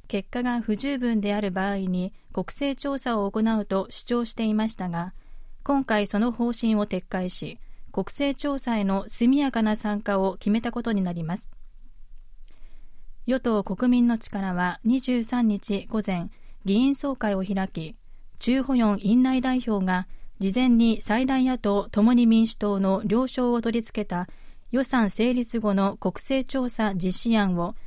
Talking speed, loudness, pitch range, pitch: 265 characters per minute, -25 LUFS, 195-245 Hz, 220 Hz